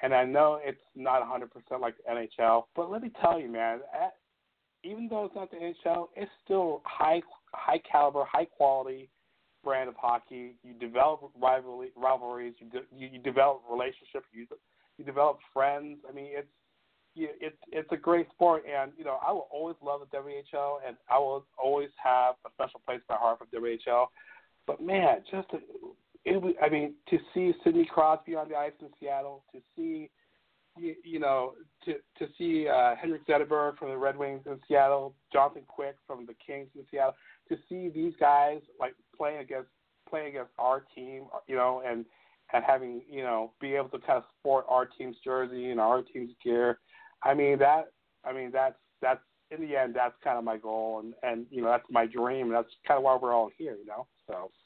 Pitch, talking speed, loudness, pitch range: 140 Hz, 200 wpm, -30 LUFS, 125-160 Hz